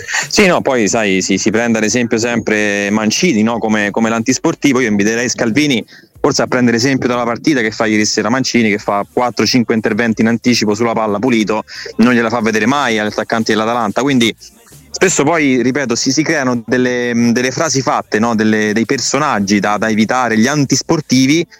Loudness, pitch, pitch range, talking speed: -13 LUFS, 115 Hz, 110-125 Hz, 185 wpm